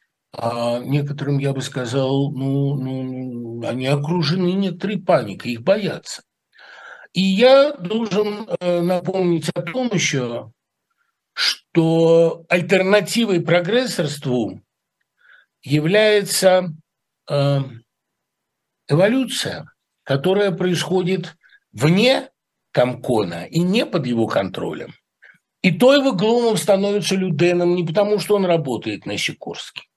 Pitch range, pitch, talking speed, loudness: 140-200 Hz, 175 Hz, 90 wpm, -19 LUFS